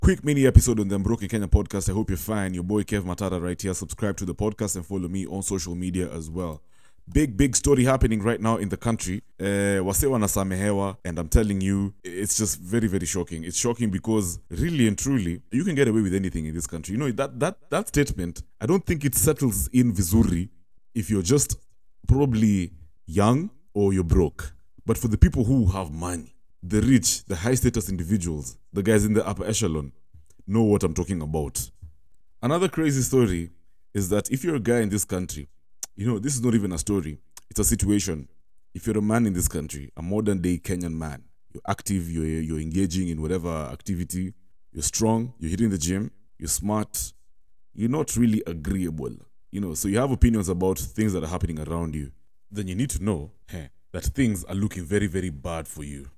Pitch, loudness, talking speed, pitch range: 100 Hz, -25 LUFS, 205 wpm, 85-110 Hz